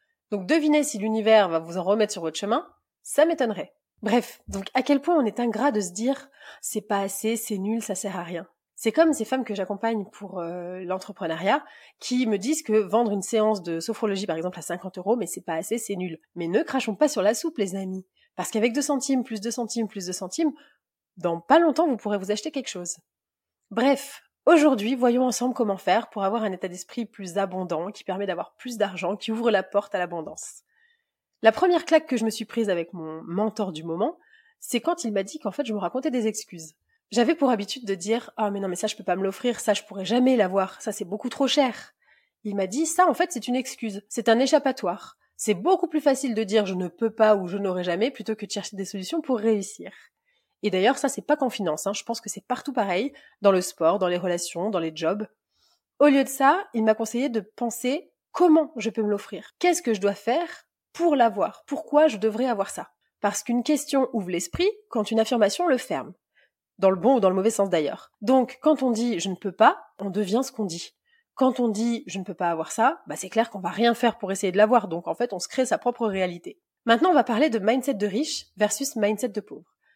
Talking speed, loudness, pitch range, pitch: 240 wpm, -25 LUFS, 195-260 Hz, 220 Hz